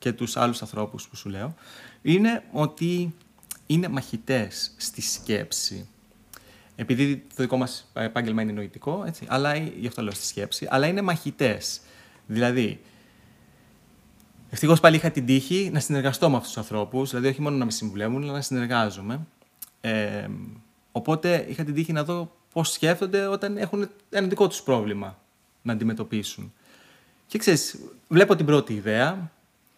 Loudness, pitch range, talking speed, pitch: -25 LUFS, 115-165 Hz, 150 wpm, 135 Hz